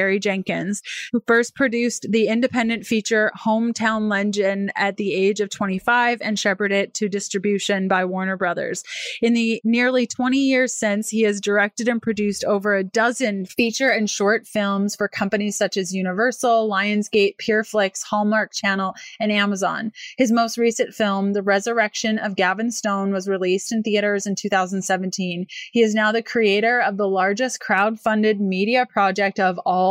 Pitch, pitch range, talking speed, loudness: 210 Hz, 200-230 Hz, 160 wpm, -20 LUFS